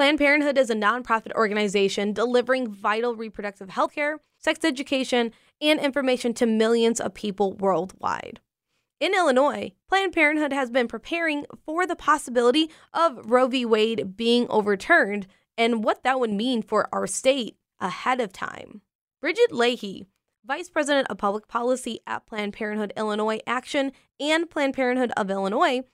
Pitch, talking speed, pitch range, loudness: 245 Hz, 150 wpm, 215-285 Hz, -24 LUFS